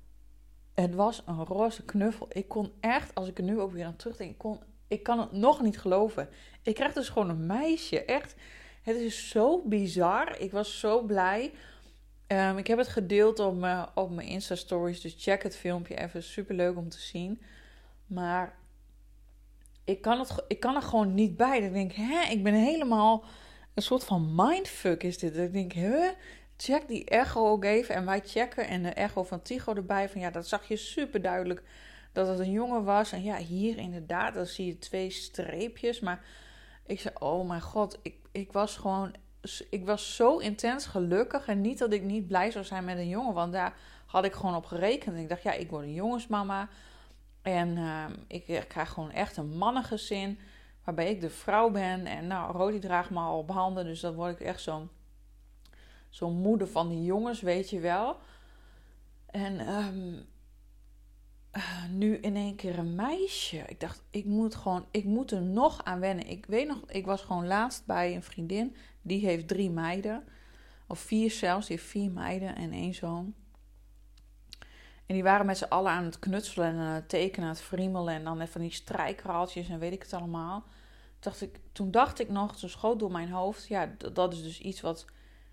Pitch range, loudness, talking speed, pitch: 175-215 Hz, -31 LUFS, 200 wpm, 190 Hz